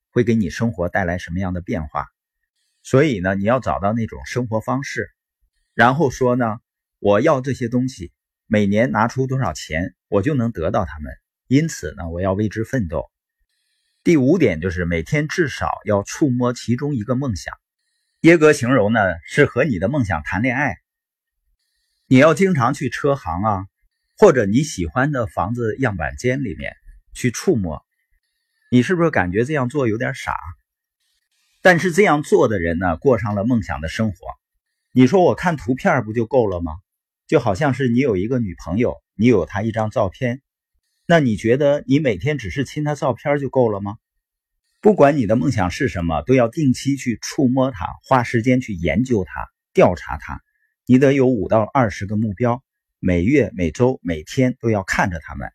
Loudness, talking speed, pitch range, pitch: -19 LUFS, 255 characters per minute, 100-140 Hz, 125 Hz